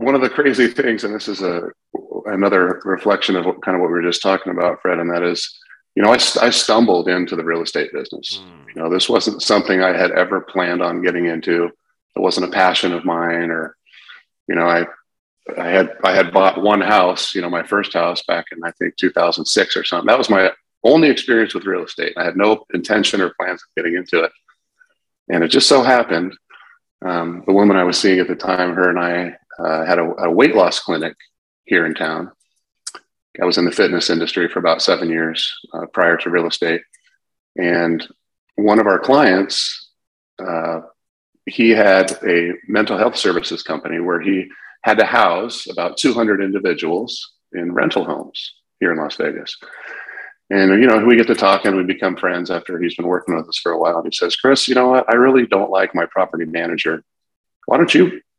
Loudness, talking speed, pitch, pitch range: -16 LUFS, 210 wpm, 90 Hz, 85-100 Hz